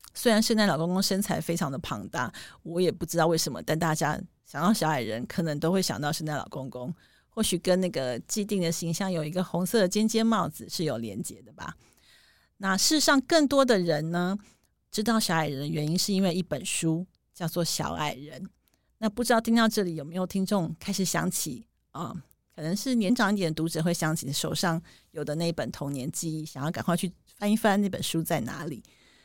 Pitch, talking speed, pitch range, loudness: 175 Hz, 305 characters per minute, 160-205 Hz, -27 LUFS